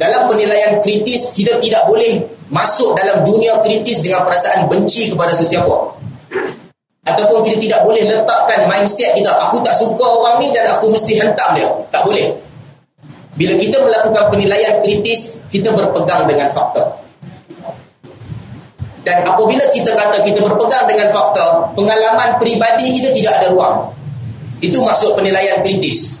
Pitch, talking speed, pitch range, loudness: 210 Hz, 140 wpm, 180-225 Hz, -12 LUFS